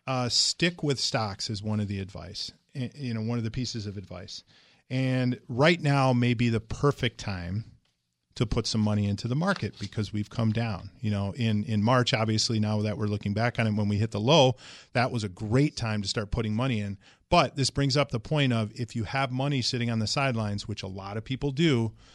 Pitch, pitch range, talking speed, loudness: 115 Hz, 105-130 Hz, 230 wpm, -27 LUFS